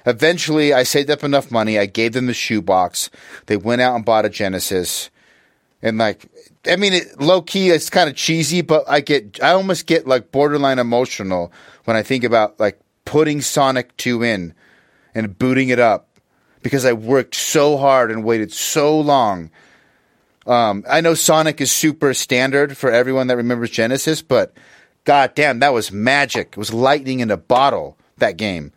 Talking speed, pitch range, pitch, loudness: 175 wpm, 110-145 Hz, 130 Hz, -16 LUFS